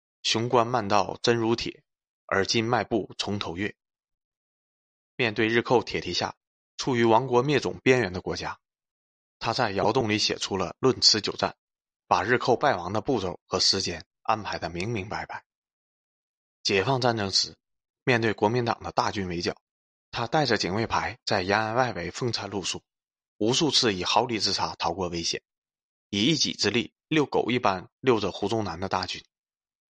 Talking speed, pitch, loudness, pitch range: 245 characters per minute, 105 Hz, -26 LUFS, 90-120 Hz